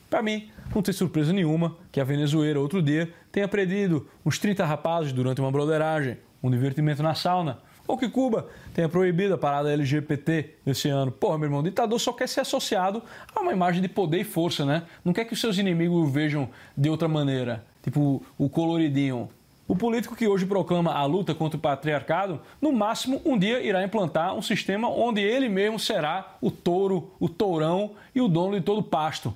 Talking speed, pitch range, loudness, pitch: 200 wpm, 150-200 Hz, -26 LUFS, 170 Hz